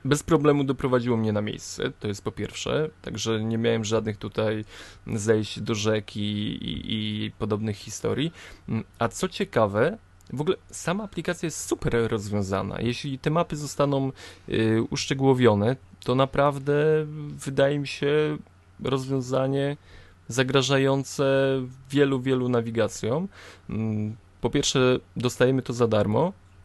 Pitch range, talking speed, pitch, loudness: 105-140 Hz, 125 wpm, 125 Hz, -26 LUFS